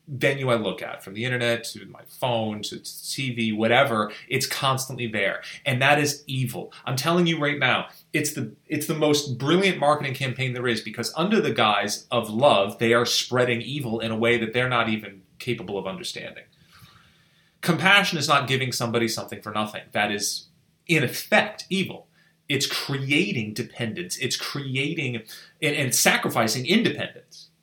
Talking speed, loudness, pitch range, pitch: 165 wpm, -23 LUFS, 115-145 Hz, 130 Hz